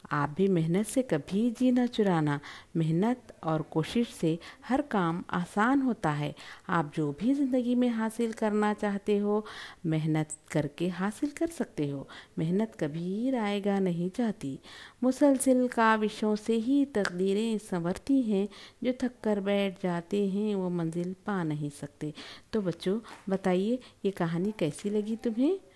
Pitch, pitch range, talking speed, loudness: 200 Hz, 170-235 Hz, 145 wpm, -30 LUFS